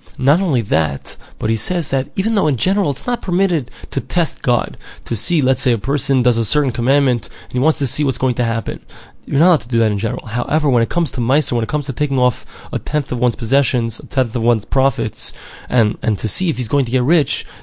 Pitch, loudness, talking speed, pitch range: 130 Hz, -17 LUFS, 260 wpm, 120-150 Hz